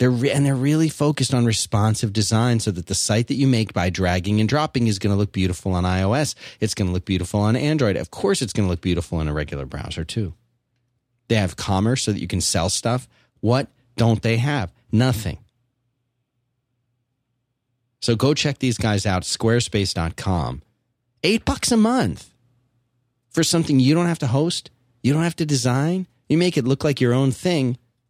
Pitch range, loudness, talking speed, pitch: 105-135 Hz, -21 LUFS, 195 wpm, 120 Hz